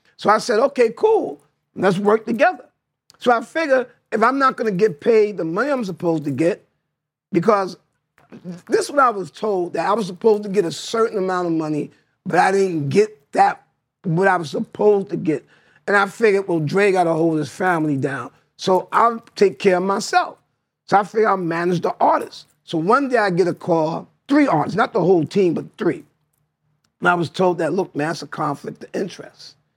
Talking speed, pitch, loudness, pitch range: 210 wpm, 195 Hz, -19 LUFS, 165-225 Hz